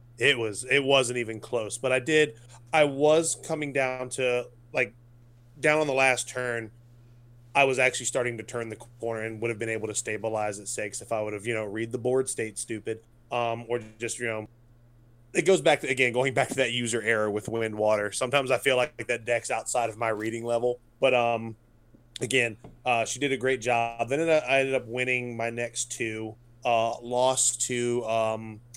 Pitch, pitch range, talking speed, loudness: 120 Hz, 115-130 Hz, 205 wpm, -27 LUFS